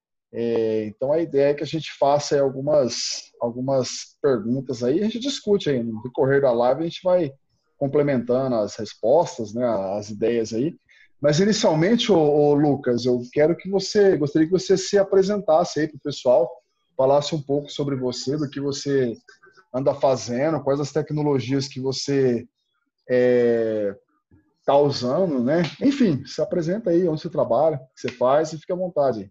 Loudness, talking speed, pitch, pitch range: -22 LUFS, 170 wpm, 140 Hz, 125-160 Hz